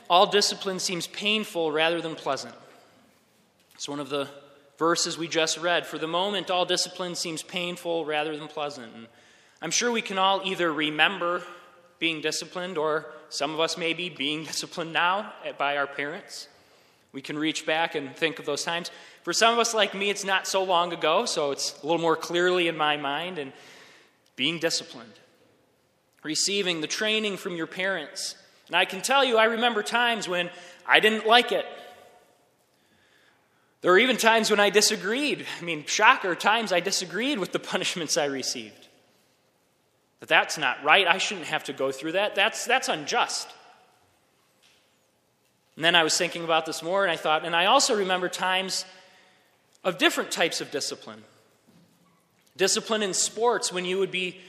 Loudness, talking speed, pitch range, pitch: -25 LUFS, 175 wpm, 155-195 Hz, 175 Hz